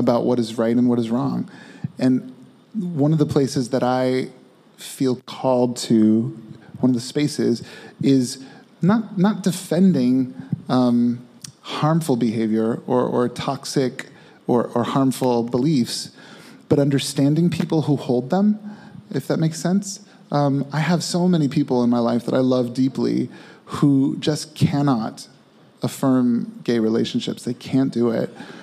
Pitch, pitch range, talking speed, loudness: 135 Hz, 125-165 Hz, 145 wpm, -21 LUFS